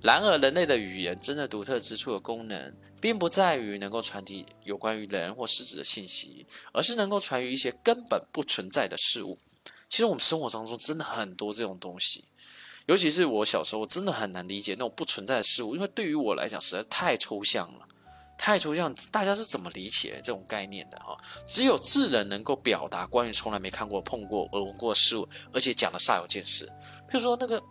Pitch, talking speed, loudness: 115 Hz, 330 characters per minute, -23 LUFS